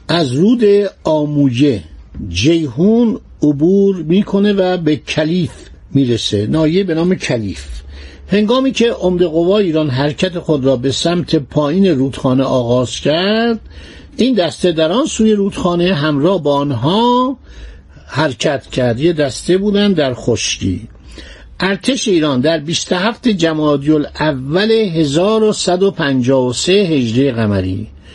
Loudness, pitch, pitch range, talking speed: -14 LUFS, 160 Hz, 130-195 Hz, 115 wpm